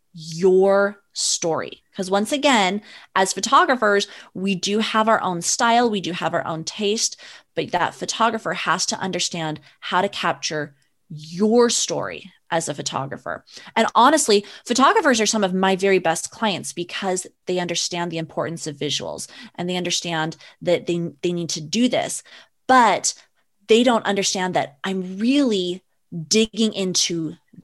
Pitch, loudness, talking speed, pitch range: 190 Hz, -20 LUFS, 150 wpm, 170-220 Hz